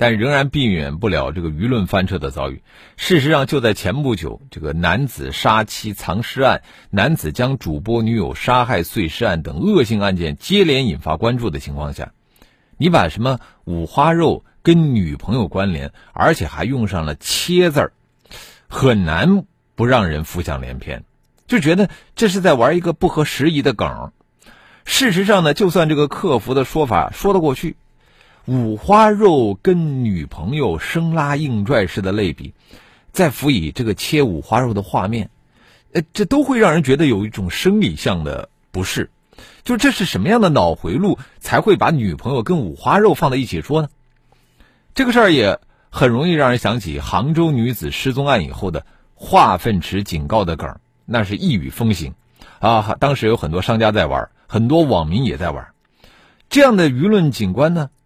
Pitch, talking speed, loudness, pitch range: 125 Hz, 260 characters per minute, -17 LUFS, 95-155 Hz